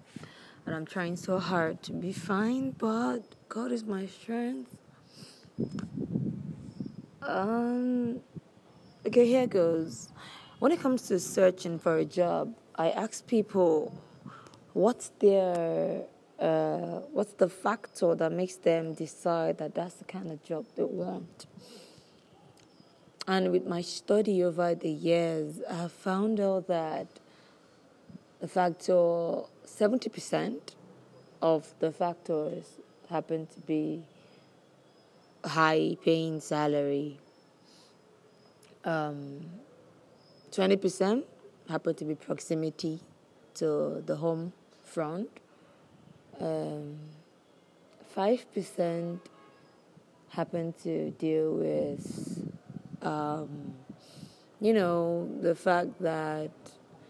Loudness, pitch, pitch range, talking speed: -31 LUFS, 170 Hz, 160-195 Hz, 100 wpm